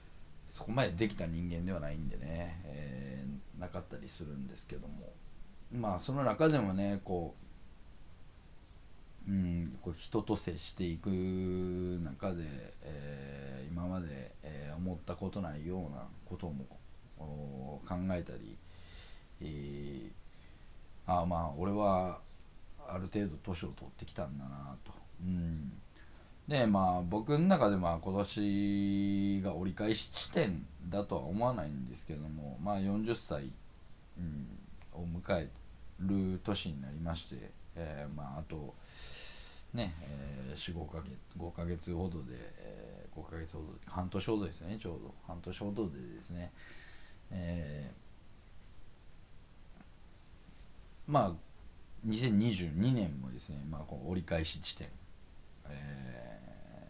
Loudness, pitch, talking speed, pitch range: -38 LUFS, 85 Hz, 220 characters per minute, 75-95 Hz